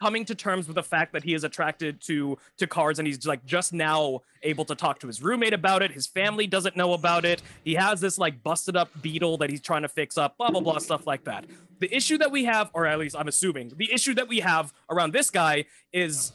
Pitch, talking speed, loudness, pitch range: 170 Hz, 255 wpm, -26 LUFS, 155-190 Hz